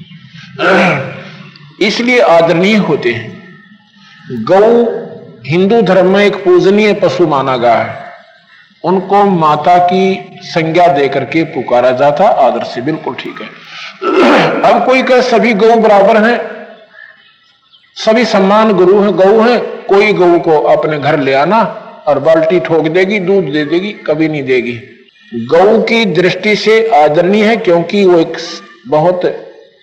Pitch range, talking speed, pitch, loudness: 165-220 Hz, 135 wpm, 190 Hz, -9 LUFS